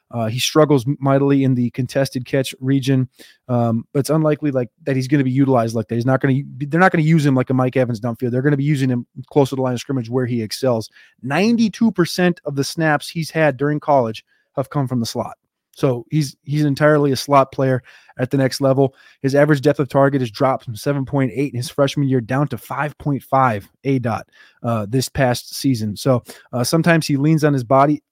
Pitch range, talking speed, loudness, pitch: 125-145 Hz, 235 wpm, -18 LUFS, 135 Hz